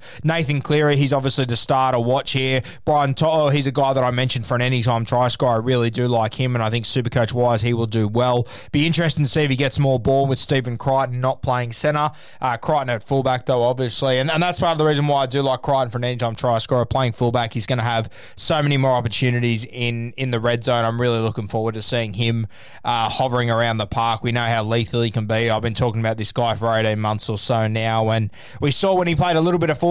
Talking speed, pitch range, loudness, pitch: 265 wpm, 115-135 Hz, -20 LUFS, 125 Hz